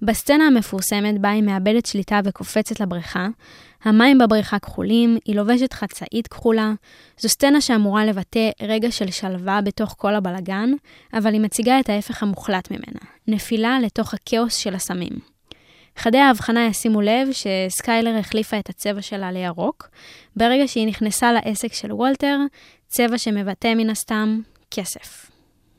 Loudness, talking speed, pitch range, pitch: -20 LUFS, 135 wpm, 205-235 Hz, 220 Hz